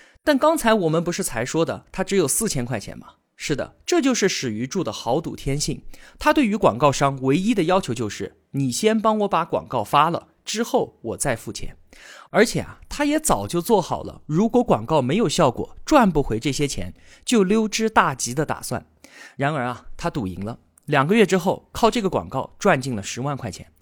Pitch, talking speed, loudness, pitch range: 170 Hz, 290 characters per minute, -22 LUFS, 130-220 Hz